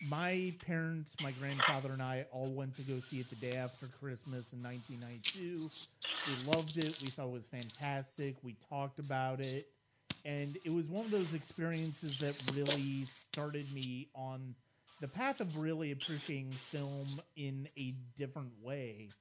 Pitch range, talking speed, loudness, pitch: 130-155 Hz, 160 wpm, -40 LUFS, 140 Hz